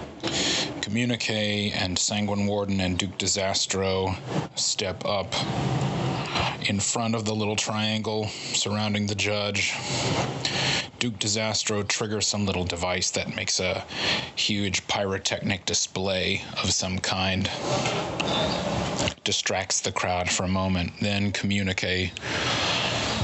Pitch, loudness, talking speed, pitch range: 100 Hz, -25 LUFS, 105 wpm, 95-105 Hz